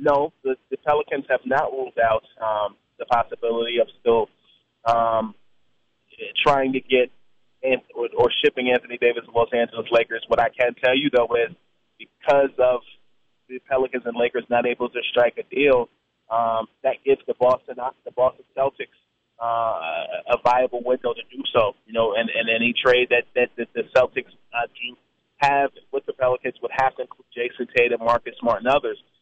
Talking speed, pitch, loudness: 180 wpm, 125 Hz, -22 LUFS